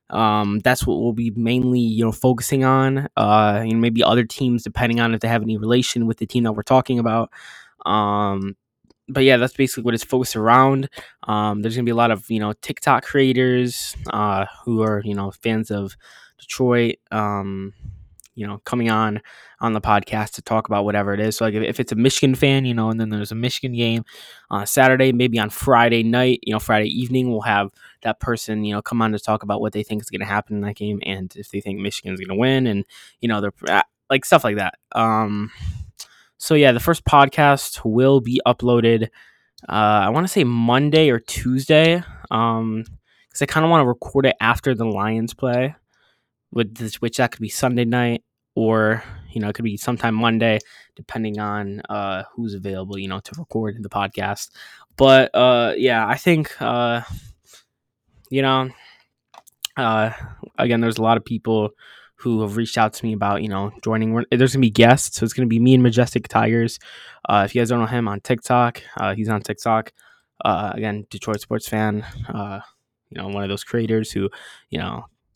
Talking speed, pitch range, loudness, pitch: 210 wpm, 105-125 Hz, -19 LUFS, 115 Hz